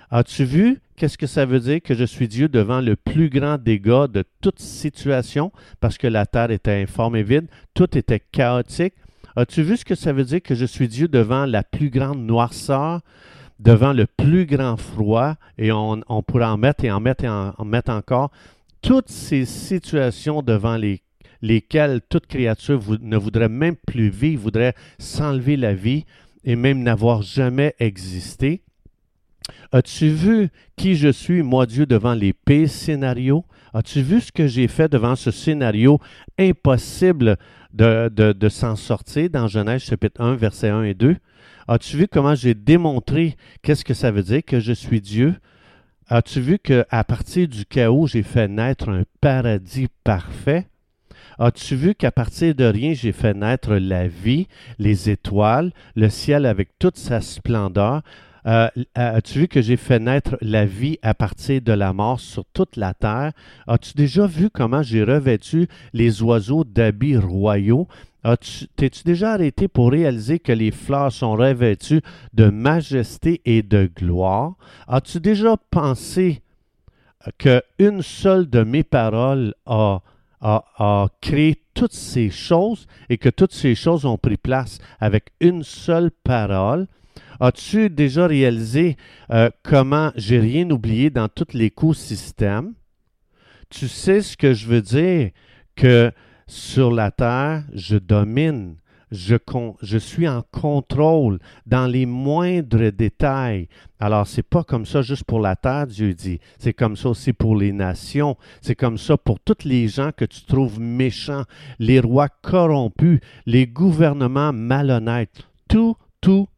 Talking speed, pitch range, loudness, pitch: 160 wpm, 110-150 Hz, -19 LUFS, 125 Hz